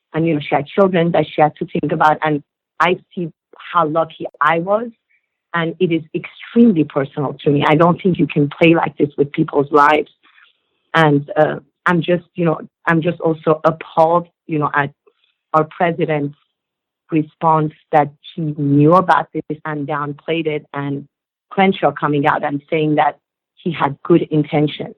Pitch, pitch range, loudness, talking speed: 155 Hz, 150-170 Hz, -17 LUFS, 175 wpm